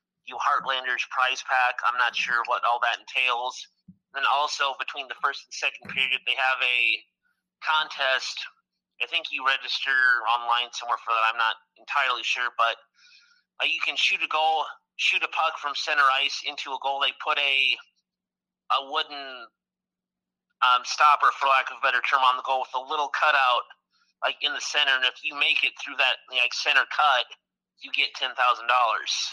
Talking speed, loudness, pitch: 180 wpm, -24 LUFS, 135 Hz